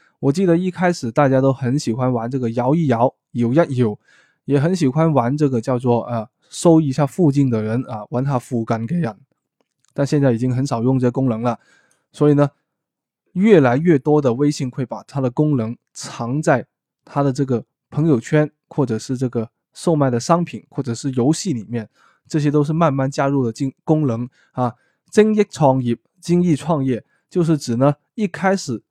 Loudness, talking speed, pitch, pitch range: -19 LUFS, 265 characters per minute, 140 Hz, 120-155 Hz